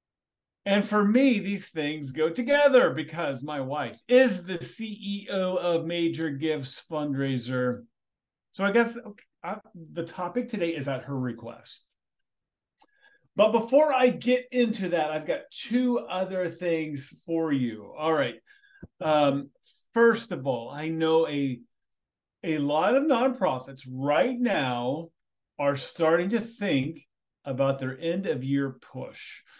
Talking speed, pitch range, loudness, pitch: 135 wpm, 145-230 Hz, -27 LUFS, 170 Hz